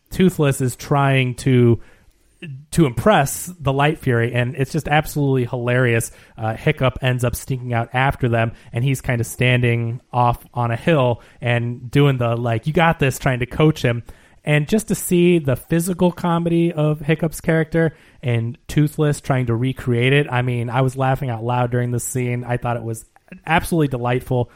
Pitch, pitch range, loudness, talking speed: 130 Hz, 120-150 Hz, -19 LUFS, 180 wpm